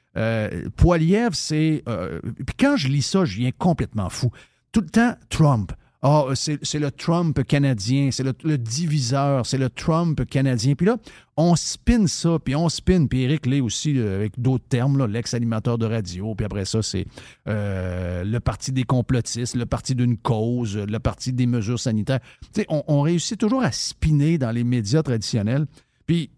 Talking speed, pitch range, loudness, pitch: 180 wpm, 115-155 Hz, -22 LUFS, 130 Hz